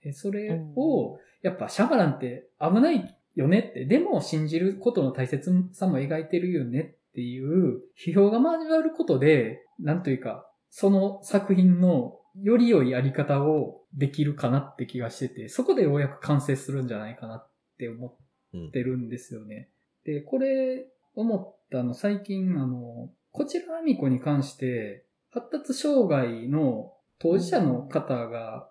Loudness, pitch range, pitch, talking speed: -26 LUFS, 130-195 Hz, 150 Hz, 295 characters per minute